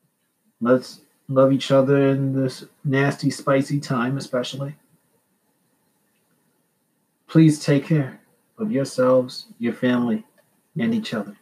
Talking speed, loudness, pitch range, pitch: 105 wpm, -21 LUFS, 130-160 Hz, 135 Hz